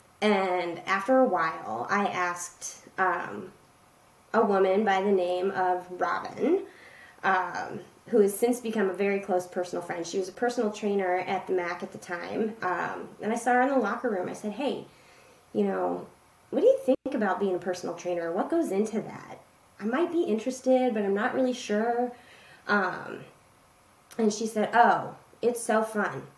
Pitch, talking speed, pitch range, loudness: 210 Hz, 180 wpm, 185-240 Hz, -28 LUFS